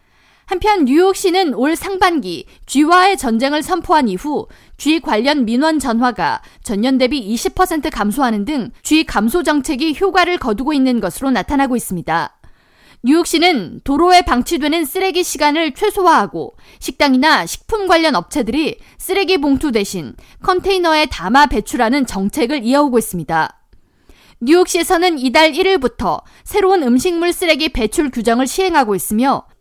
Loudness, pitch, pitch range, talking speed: -15 LUFS, 300 Hz, 245-350 Hz, 320 characters per minute